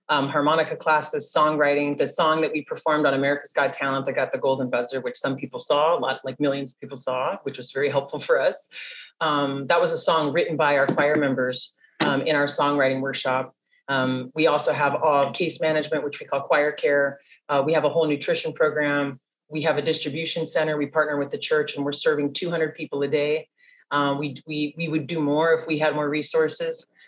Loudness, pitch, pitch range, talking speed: -23 LUFS, 145 Hz, 140-155 Hz, 215 wpm